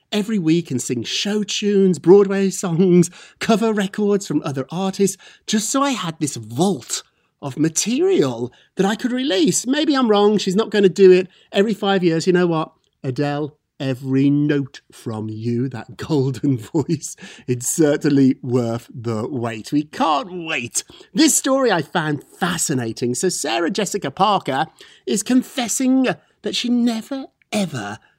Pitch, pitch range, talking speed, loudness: 180 Hz, 140-210 Hz, 150 wpm, -19 LUFS